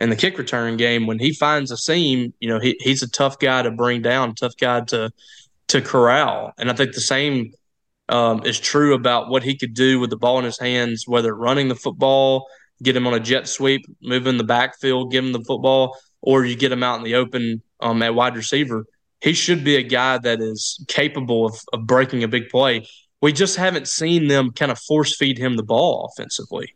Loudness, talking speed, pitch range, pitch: -19 LUFS, 225 wpm, 120-135 Hz, 125 Hz